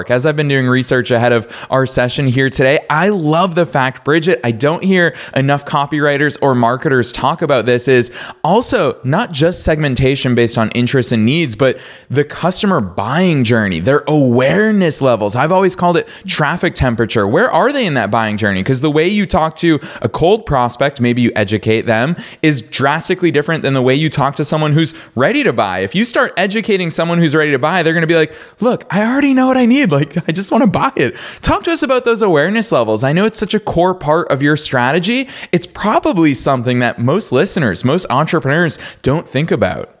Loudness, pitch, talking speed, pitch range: -13 LUFS, 150 Hz, 210 wpm, 130-175 Hz